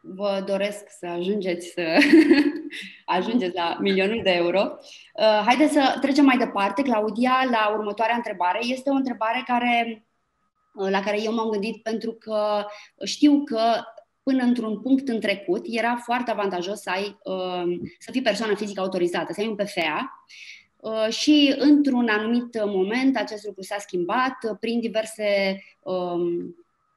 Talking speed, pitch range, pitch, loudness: 135 wpm, 200-255 Hz, 220 Hz, -23 LUFS